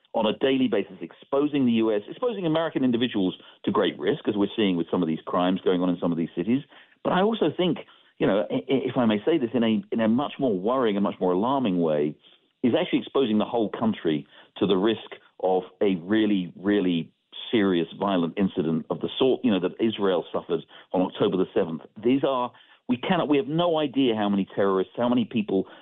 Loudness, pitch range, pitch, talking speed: -25 LUFS, 90-130 Hz, 105 Hz, 215 wpm